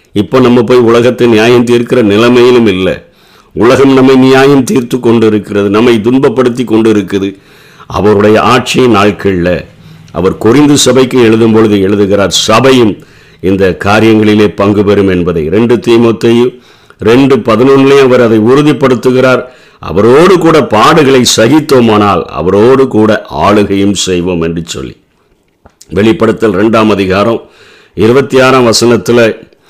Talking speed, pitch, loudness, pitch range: 115 wpm, 115 Hz, -6 LUFS, 105-130 Hz